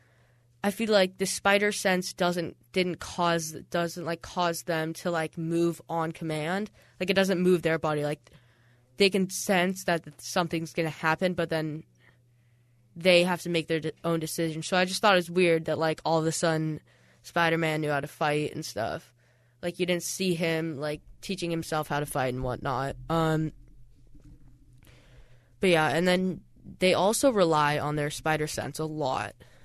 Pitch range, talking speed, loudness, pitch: 150-180 Hz, 180 wpm, -27 LUFS, 160 Hz